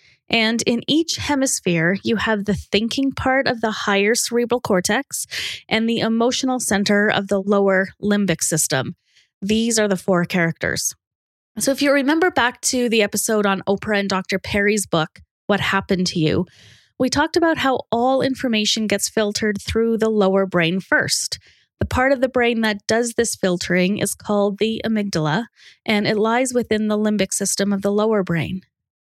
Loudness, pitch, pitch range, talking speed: -19 LUFS, 210 Hz, 195-235 Hz, 170 wpm